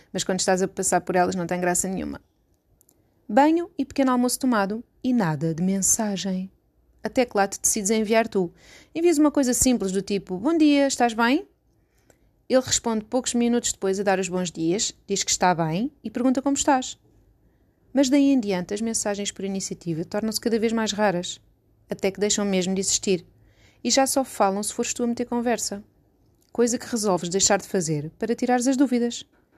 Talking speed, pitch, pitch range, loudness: 195 wpm, 215 Hz, 190-250 Hz, -23 LUFS